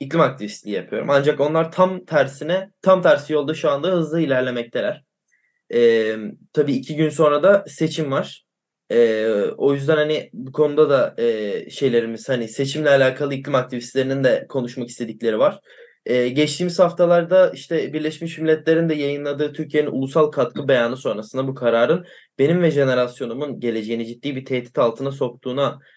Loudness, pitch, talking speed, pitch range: -20 LUFS, 145 Hz, 150 wpm, 125-160 Hz